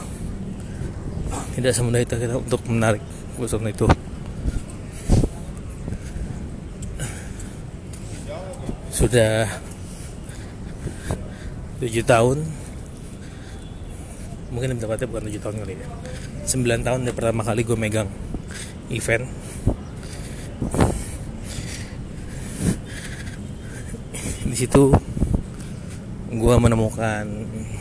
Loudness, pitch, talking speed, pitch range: -24 LUFS, 110 Hz, 65 wpm, 100-120 Hz